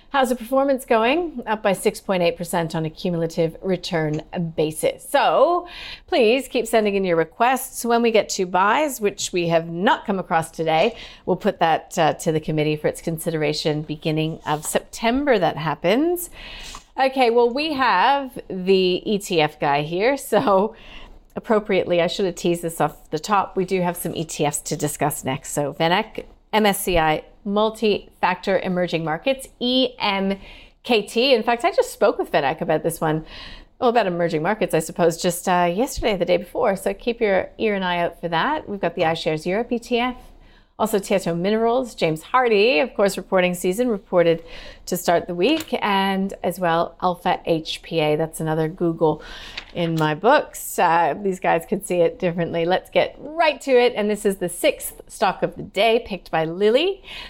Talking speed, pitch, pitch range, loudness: 175 wpm, 185 Hz, 165-230 Hz, -21 LUFS